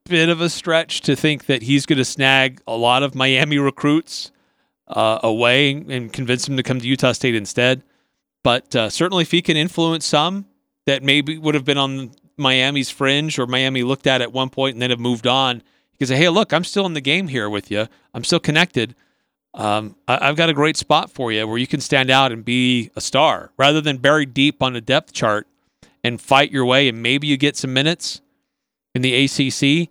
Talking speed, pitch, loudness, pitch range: 220 wpm, 135 Hz, -17 LUFS, 125-150 Hz